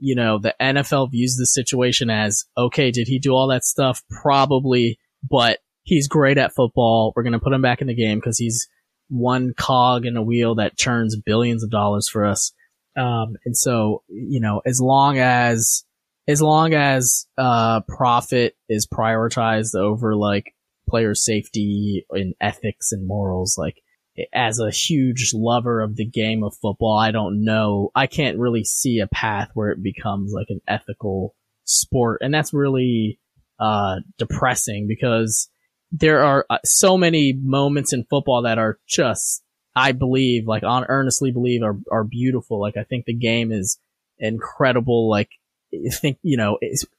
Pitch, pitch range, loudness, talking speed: 120 Hz, 110-130 Hz, -19 LUFS, 165 wpm